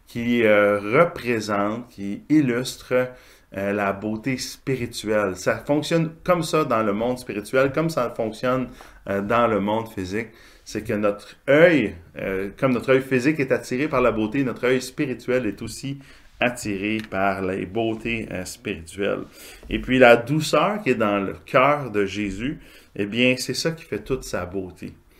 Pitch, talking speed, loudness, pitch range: 115 Hz, 165 wpm, -22 LUFS, 100-130 Hz